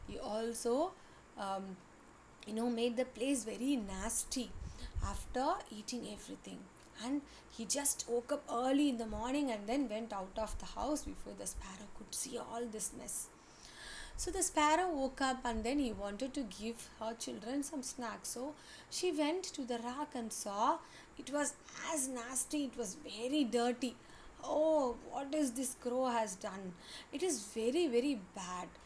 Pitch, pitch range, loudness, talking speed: 250 Hz, 230-285 Hz, -38 LUFS, 165 wpm